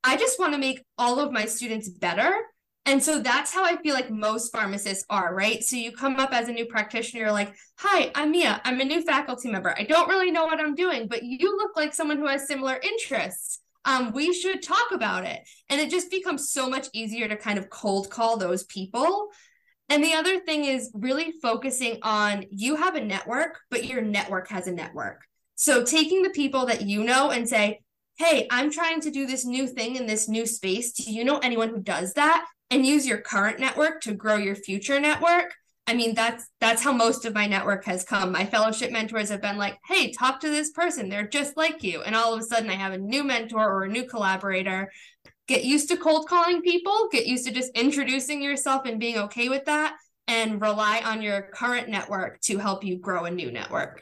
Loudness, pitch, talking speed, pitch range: -25 LUFS, 245 Hz, 225 wpm, 215-300 Hz